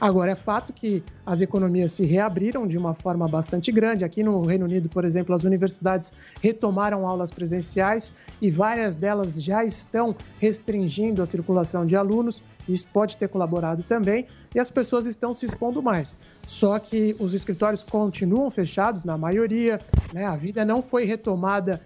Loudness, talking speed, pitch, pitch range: -24 LUFS, 165 wpm, 200 Hz, 180-220 Hz